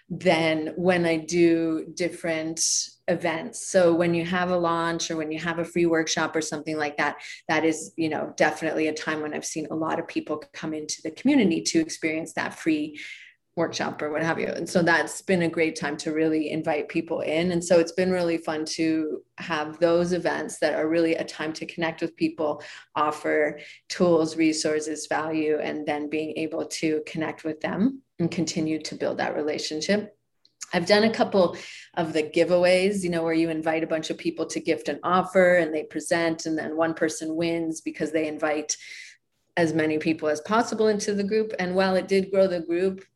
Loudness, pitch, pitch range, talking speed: -25 LUFS, 165 Hz, 155-175 Hz, 200 wpm